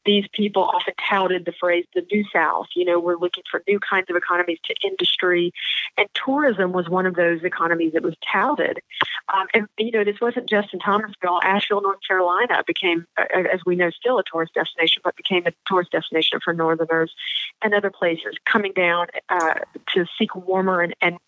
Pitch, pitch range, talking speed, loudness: 185 Hz, 175-205 Hz, 190 wpm, -21 LUFS